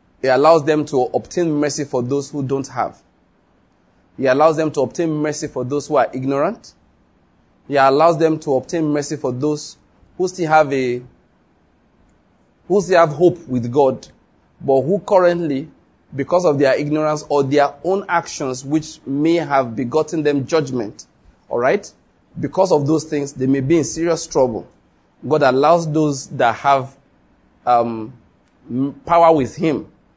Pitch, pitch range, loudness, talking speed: 145 Hz, 130-160 Hz, -18 LUFS, 155 wpm